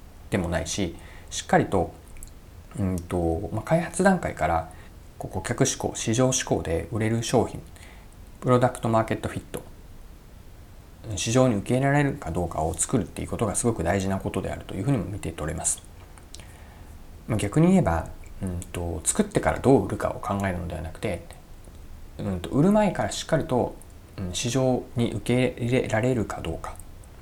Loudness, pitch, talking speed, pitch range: -26 LUFS, 95 Hz, 330 characters per minute, 85-115 Hz